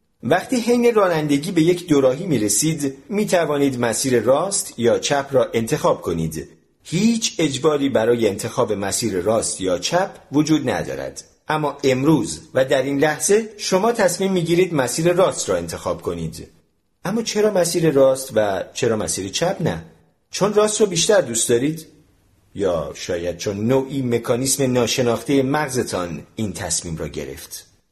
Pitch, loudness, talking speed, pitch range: 145 Hz, -19 LUFS, 145 wpm, 115-180 Hz